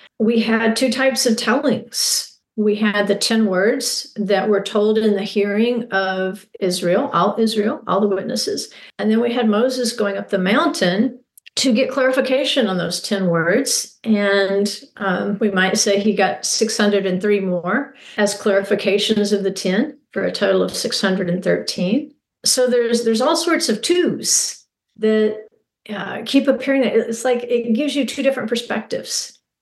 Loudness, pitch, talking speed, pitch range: -18 LUFS, 220 Hz, 160 wpm, 200-245 Hz